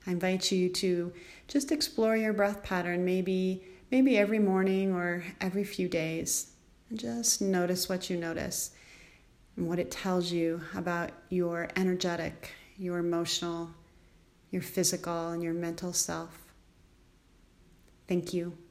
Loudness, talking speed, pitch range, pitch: -31 LUFS, 130 wpm, 170-190 Hz, 180 Hz